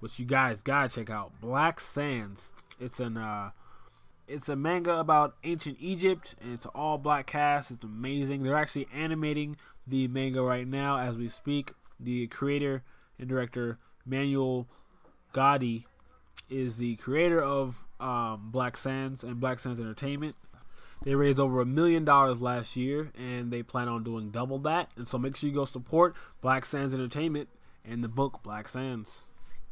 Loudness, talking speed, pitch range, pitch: -30 LUFS, 160 wpm, 120-145 Hz, 130 Hz